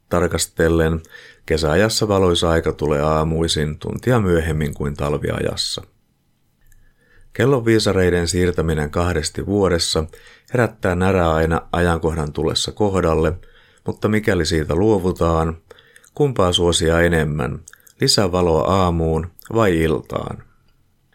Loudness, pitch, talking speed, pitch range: -18 LUFS, 85 Hz, 90 wpm, 80-95 Hz